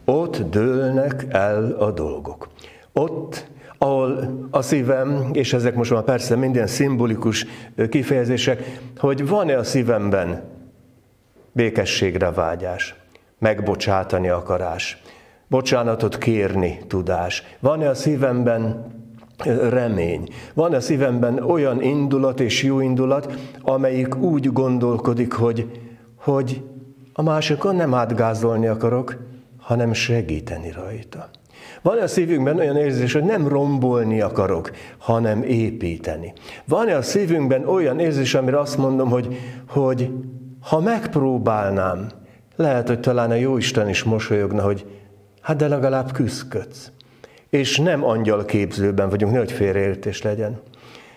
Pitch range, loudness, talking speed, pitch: 110-135 Hz, -20 LUFS, 115 wpm, 125 Hz